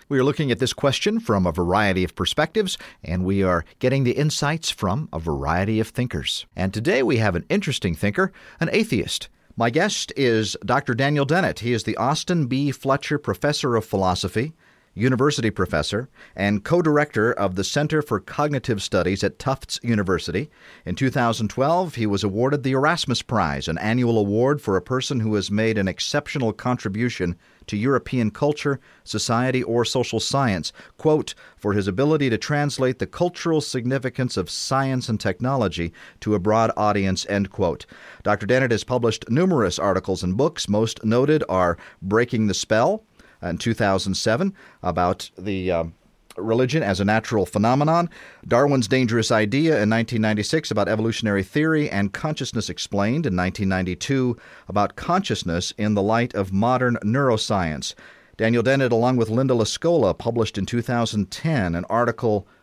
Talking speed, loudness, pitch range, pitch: 155 wpm, -22 LUFS, 100-135 Hz, 115 Hz